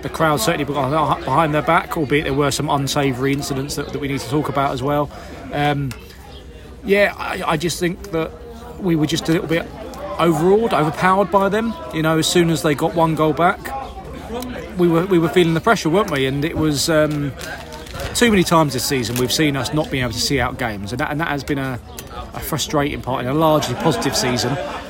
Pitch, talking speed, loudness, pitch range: 150 Hz, 220 wpm, -18 LUFS, 135-165 Hz